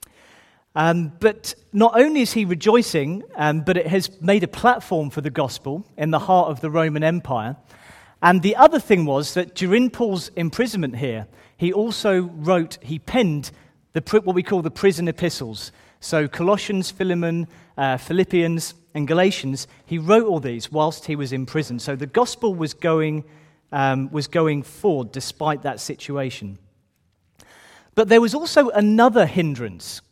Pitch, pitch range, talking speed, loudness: 165 Hz, 140-190 Hz, 160 wpm, -20 LUFS